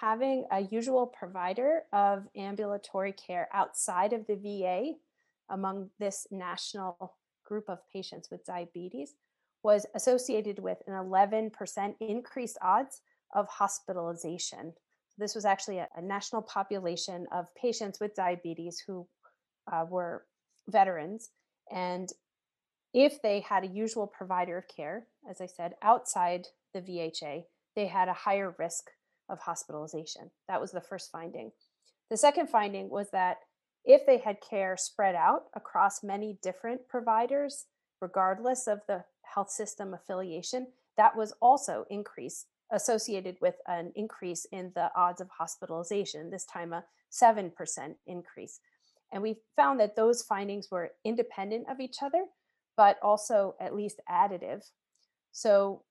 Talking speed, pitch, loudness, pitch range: 135 wpm, 200 Hz, -31 LUFS, 180-225 Hz